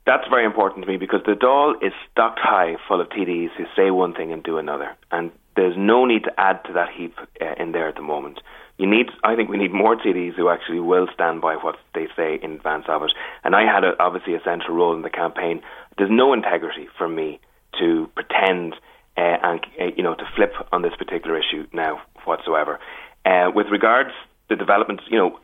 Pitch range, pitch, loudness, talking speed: 80-95 Hz, 90 Hz, -20 LUFS, 225 wpm